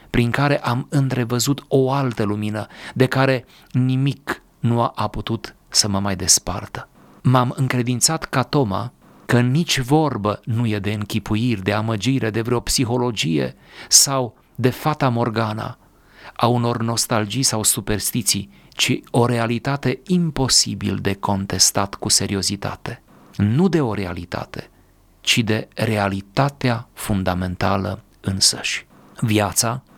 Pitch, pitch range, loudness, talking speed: 115 Hz, 105-130 Hz, -20 LUFS, 120 wpm